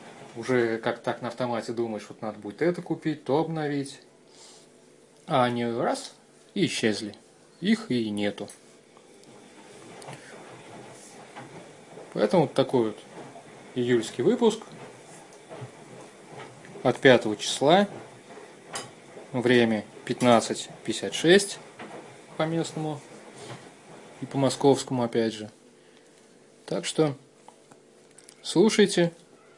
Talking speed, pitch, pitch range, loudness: 85 wpm, 125 Hz, 110-155 Hz, -26 LUFS